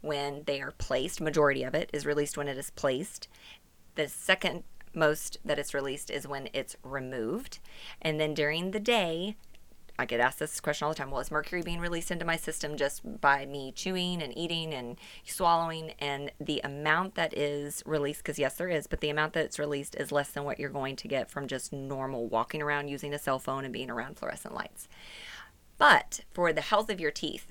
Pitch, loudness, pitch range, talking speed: 150 Hz, -31 LUFS, 140-165 Hz, 210 wpm